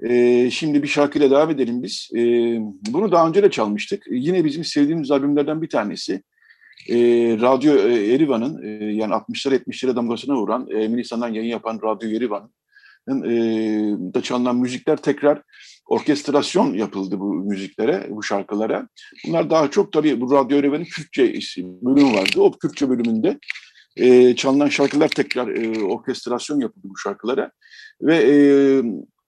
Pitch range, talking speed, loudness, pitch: 115-150 Hz, 125 wpm, -19 LUFS, 130 Hz